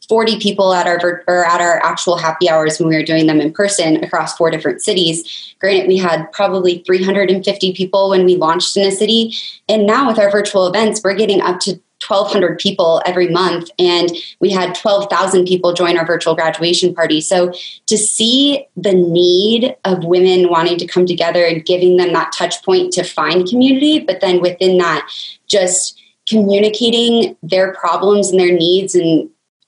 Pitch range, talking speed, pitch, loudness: 175-200 Hz, 180 wpm, 185 Hz, -13 LUFS